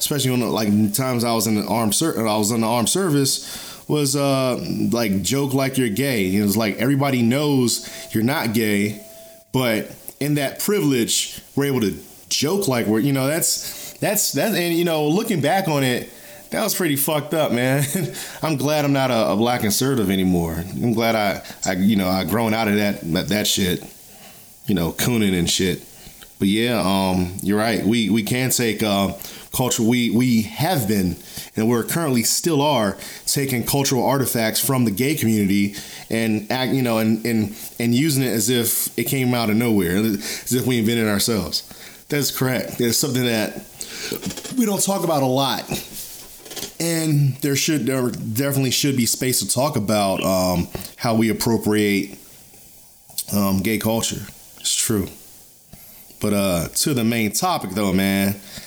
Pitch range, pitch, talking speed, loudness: 105-135 Hz, 120 Hz, 180 wpm, -20 LUFS